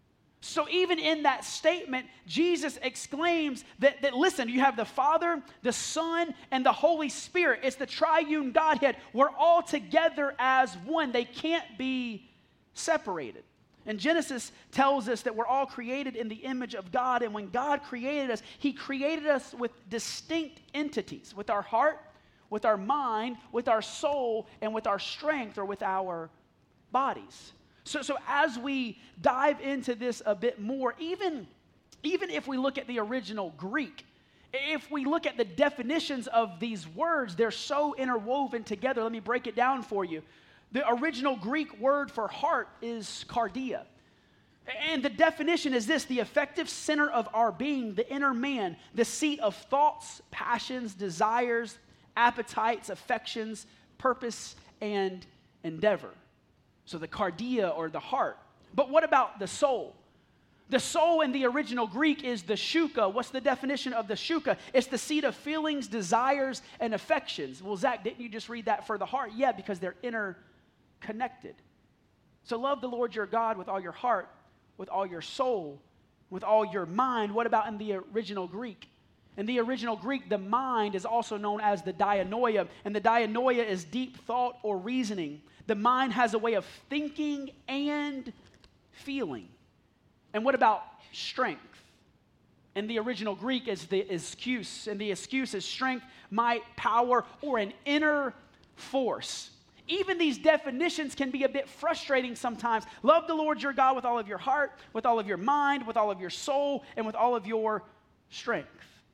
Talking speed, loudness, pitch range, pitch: 165 wpm, -30 LUFS, 220-285 Hz, 250 Hz